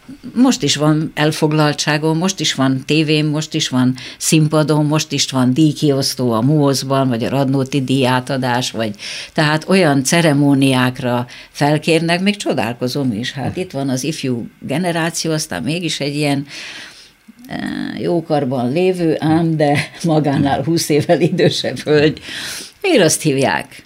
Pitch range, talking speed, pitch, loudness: 135-160 Hz, 130 wpm, 150 Hz, -16 LUFS